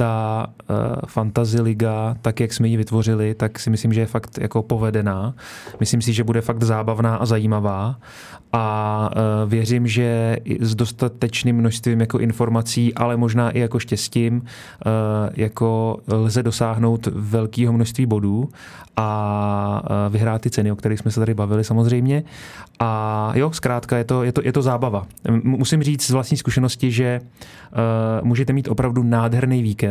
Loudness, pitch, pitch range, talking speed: -20 LUFS, 115 Hz, 110-120 Hz, 150 wpm